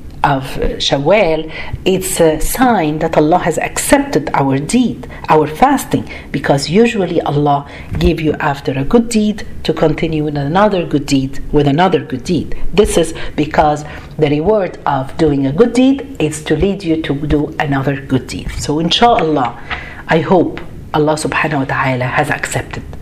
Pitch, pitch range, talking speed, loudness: 155 Hz, 145-180 Hz, 160 wpm, -14 LUFS